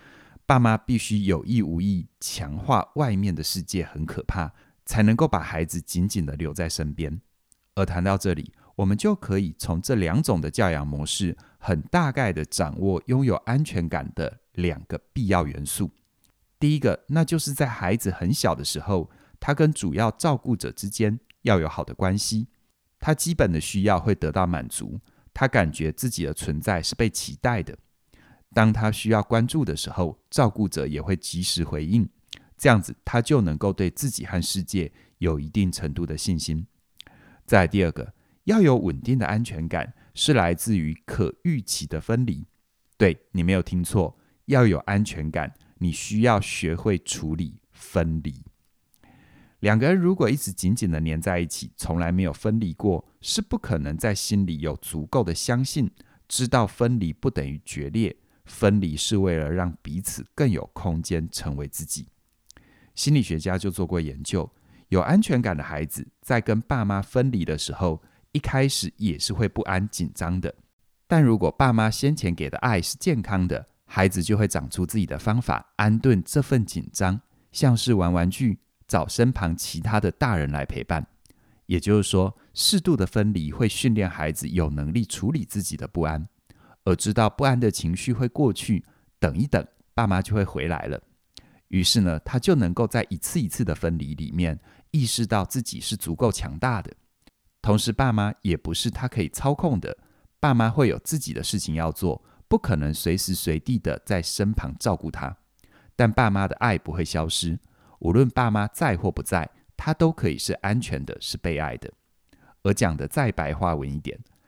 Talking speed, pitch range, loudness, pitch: 260 characters per minute, 80-115 Hz, -24 LUFS, 95 Hz